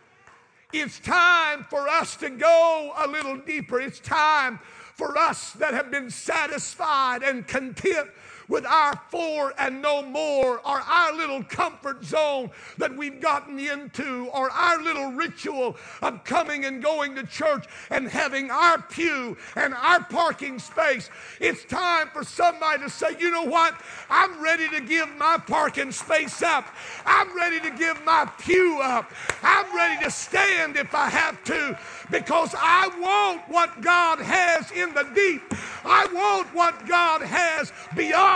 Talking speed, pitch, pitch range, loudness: 155 wpm, 315 Hz, 285-345 Hz, -23 LUFS